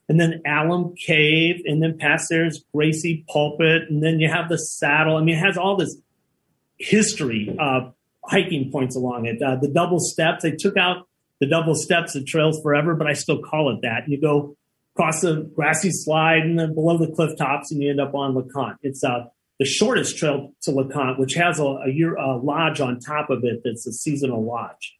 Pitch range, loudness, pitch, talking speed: 140-165 Hz, -21 LUFS, 155 Hz, 210 wpm